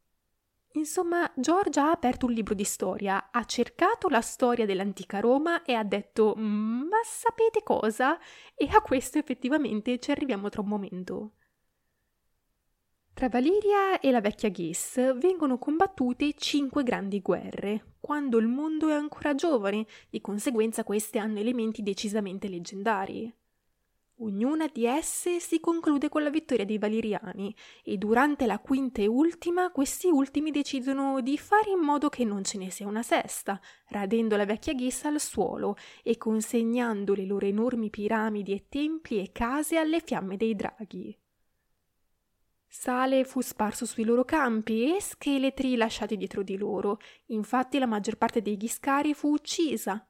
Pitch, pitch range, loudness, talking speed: 240 Hz, 210-295 Hz, -28 LUFS, 145 wpm